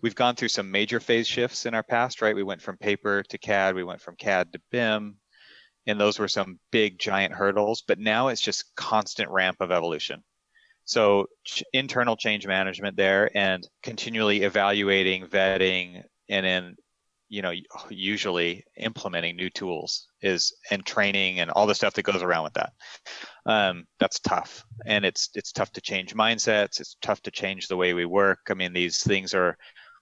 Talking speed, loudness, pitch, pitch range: 180 wpm, -25 LUFS, 100 Hz, 95-110 Hz